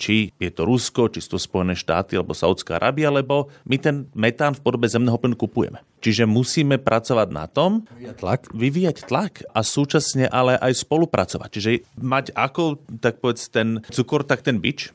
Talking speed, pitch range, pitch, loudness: 175 wpm, 115-140 Hz, 125 Hz, -21 LUFS